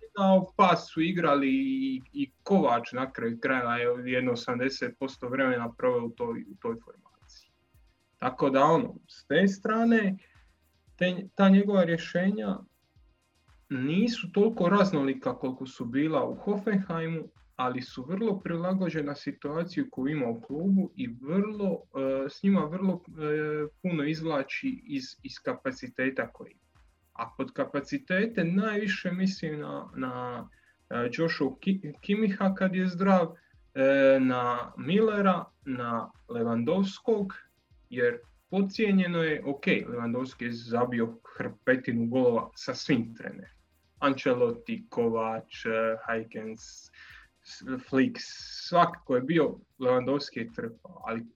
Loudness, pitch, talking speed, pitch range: -29 LUFS, 160 Hz, 120 wpm, 130-195 Hz